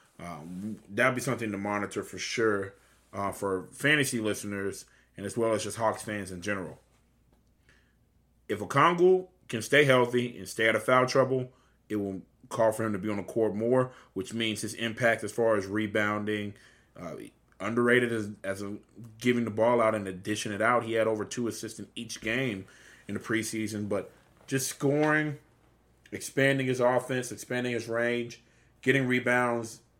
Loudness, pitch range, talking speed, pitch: -29 LUFS, 105-125 Hz, 175 wpm, 110 Hz